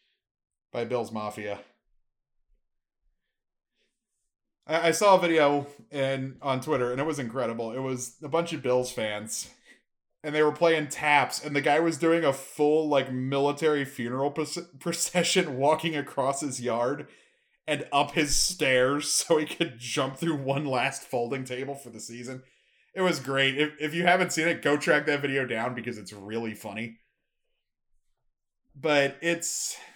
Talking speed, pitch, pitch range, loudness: 155 wpm, 140 Hz, 125-155 Hz, -27 LUFS